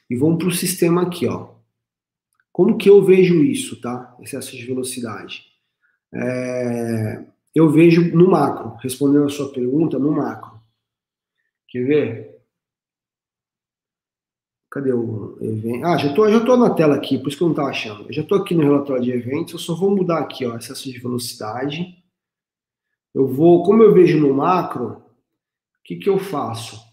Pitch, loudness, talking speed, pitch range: 140 Hz, -18 LUFS, 170 wpm, 125-175 Hz